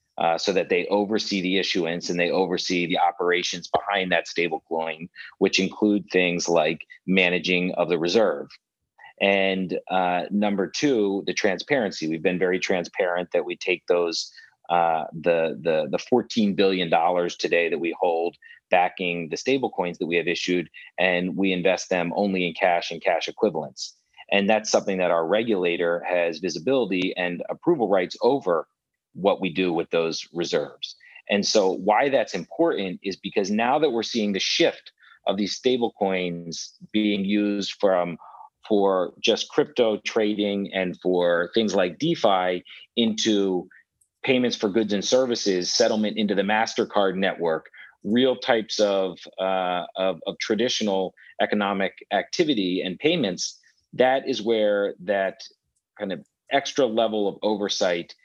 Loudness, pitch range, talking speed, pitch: -24 LUFS, 90-105 Hz, 150 wpm, 95 Hz